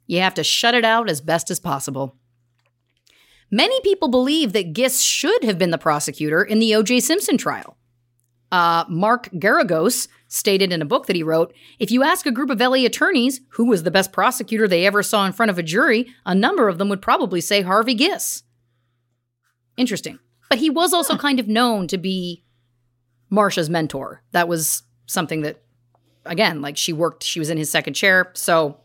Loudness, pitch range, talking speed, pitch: -19 LUFS, 150-235 Hz, 190 wpm, 185 Hz